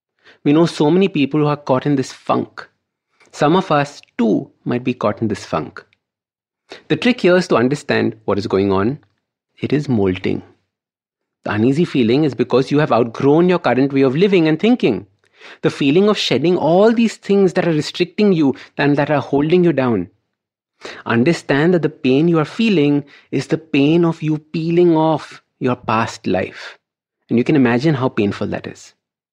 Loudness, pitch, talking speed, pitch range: -16 LUFS, 145 Hz, 185 wpm, 125-170 Hz